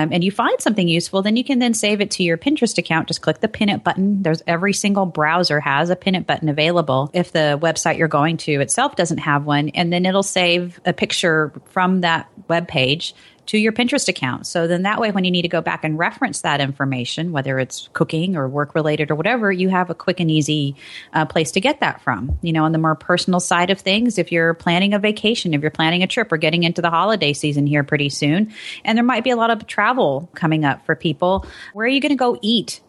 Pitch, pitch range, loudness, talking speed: 175 Hz, 155-200 Hz, -18 LUFS, 250 wpm